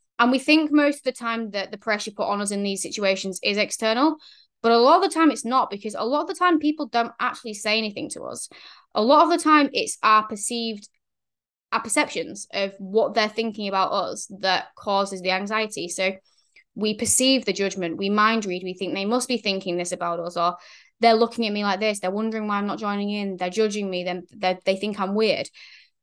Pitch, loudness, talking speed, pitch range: 215 Hz, -23 LUFS, 225 wpm, 195-235 Hz